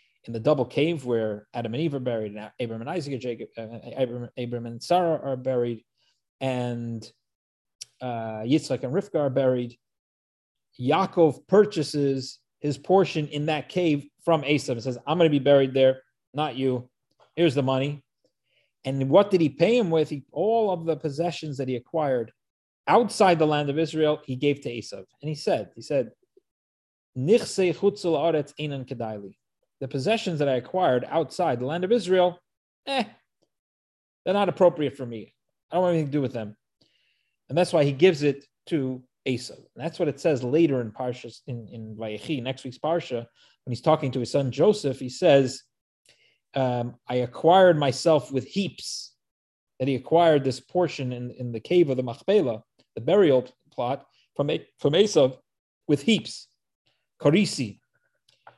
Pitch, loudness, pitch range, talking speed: 140 Hz, -25 LUFS, 125-165 Hz, 170 wpm